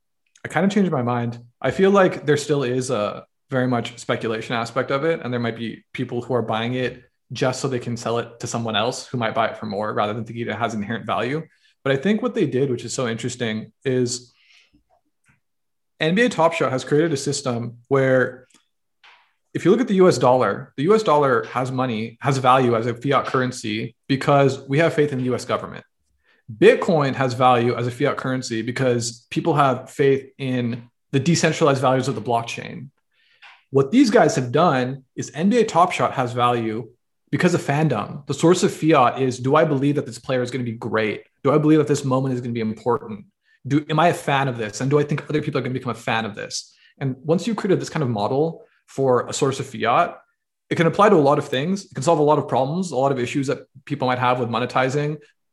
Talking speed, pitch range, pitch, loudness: 230 wpm, 120-150 Hz, 130 Hz, -21 LUFS